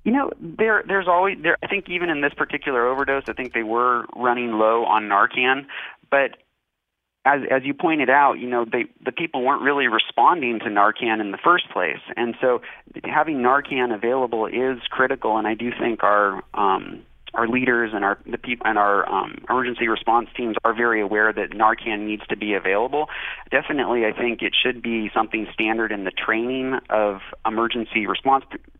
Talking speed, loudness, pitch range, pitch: 185 wpm, -21 LUFS, 110-130 Hz, 120 Hz